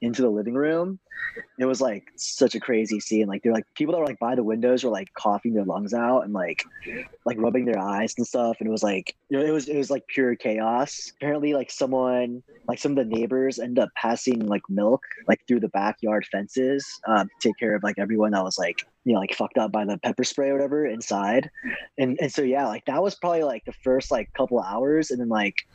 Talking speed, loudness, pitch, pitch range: 245 wpm, -25 LUFS, 120 Hz, 110-135 Hz